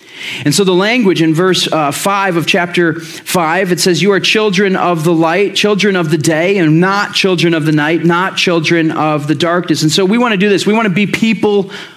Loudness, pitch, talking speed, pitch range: -11 LUFS, 180 Hz, 230 wpm, 165-200 Hz